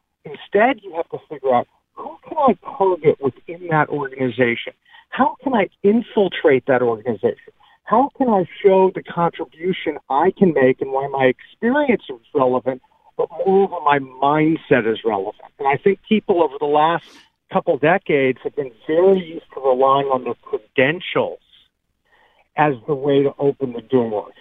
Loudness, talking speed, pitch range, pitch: -19 LUFS, 160 wpm, 135-225 Hz, 170 Hz